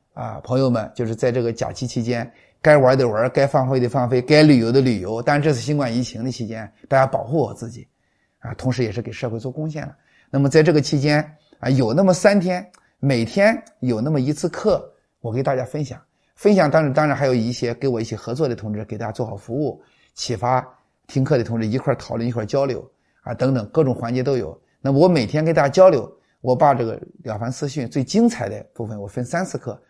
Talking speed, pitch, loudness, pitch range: 325 characters per minute, 130 Hz, -20 LUFS, 120-150 Hz